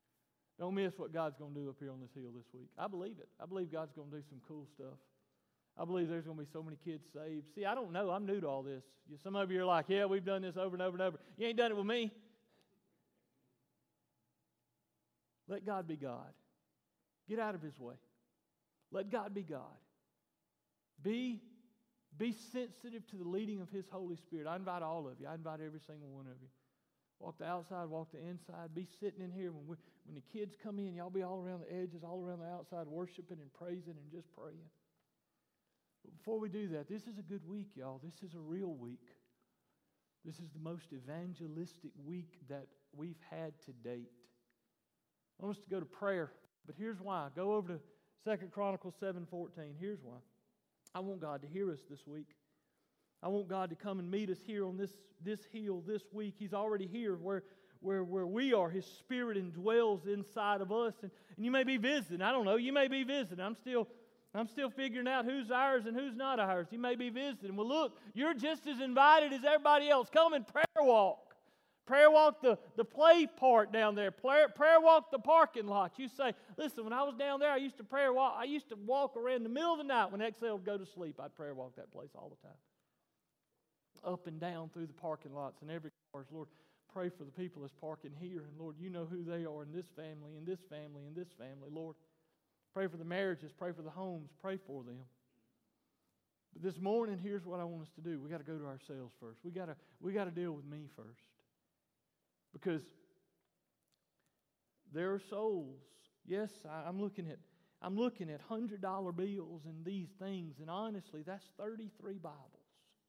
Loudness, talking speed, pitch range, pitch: -37 LUFS, 215 wpm, 160-215 Hz, 185 Hz